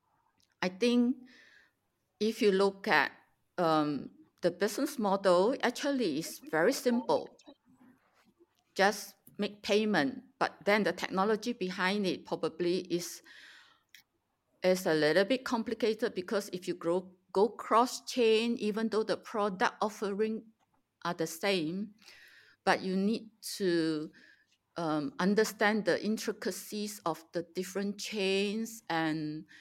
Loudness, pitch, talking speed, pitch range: -32 LUFS, 205 Hz, 120 wpm, 180-225 Hz